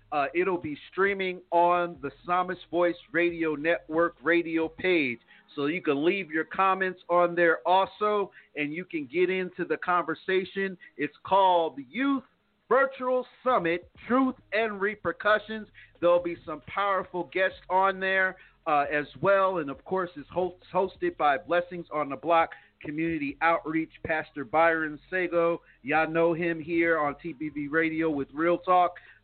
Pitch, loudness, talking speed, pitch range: 175 Hz, -27 LUFS, 150 wpm, 160-190 Hz